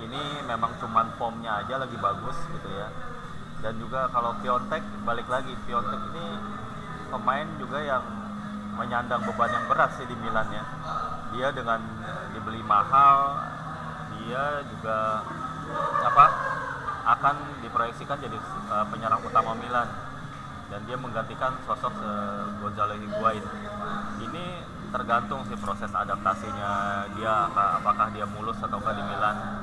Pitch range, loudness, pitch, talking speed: 100-120 Hz, -27 LUFS, 105 Hz, 120 wpm